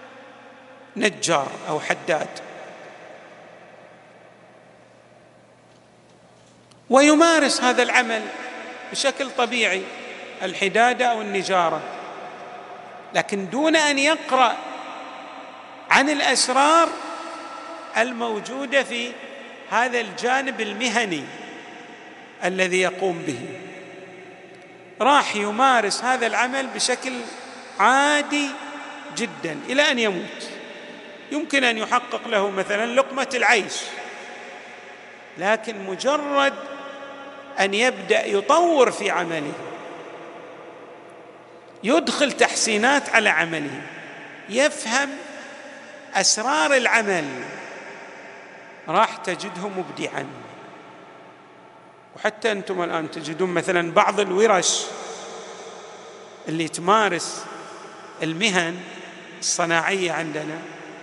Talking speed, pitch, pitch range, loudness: 70 wpm, 220 Hz, 180-265 Hz, -21 LUFS